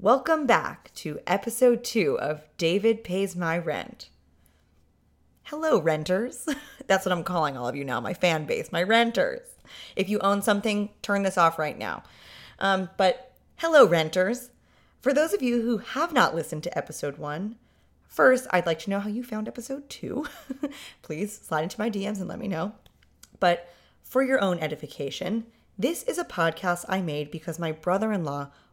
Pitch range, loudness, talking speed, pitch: 165-235 Hz, -26 LUFS, 175 wpm, 195 Hz